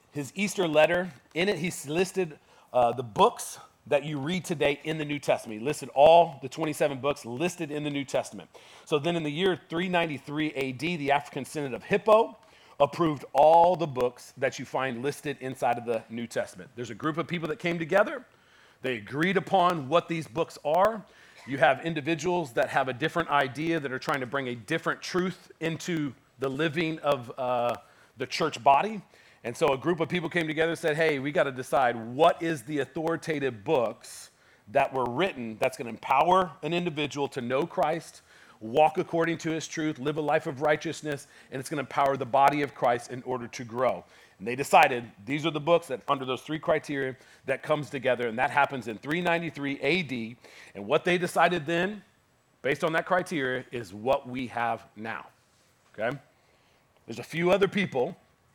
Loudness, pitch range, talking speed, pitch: -28 LUFS, 130-170 Hz, 190 wpm, 150 Hz